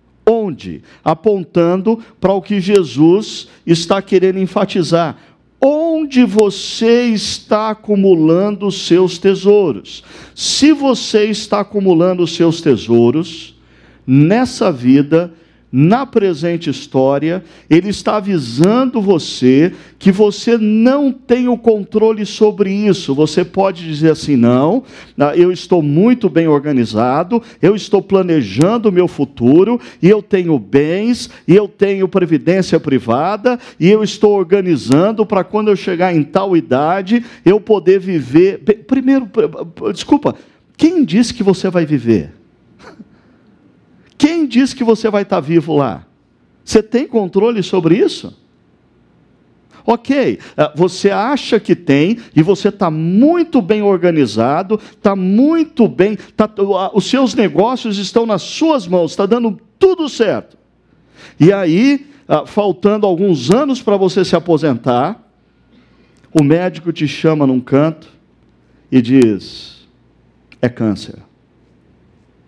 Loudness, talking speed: -13 LUFS, 120 wpm